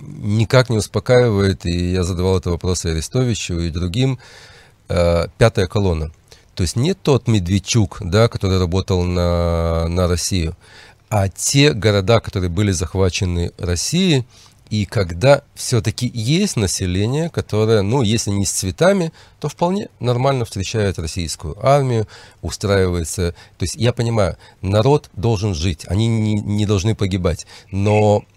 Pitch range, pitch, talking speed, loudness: 90-115 Hz, 105 Hz, 135 wpm, -18 LUFS